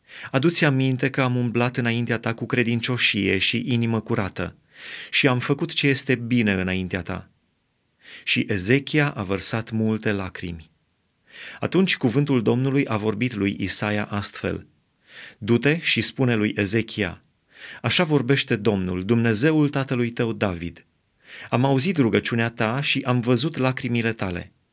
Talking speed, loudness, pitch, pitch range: 135 wpm, -21 LUFS, 115 Hz, 105-130 Hz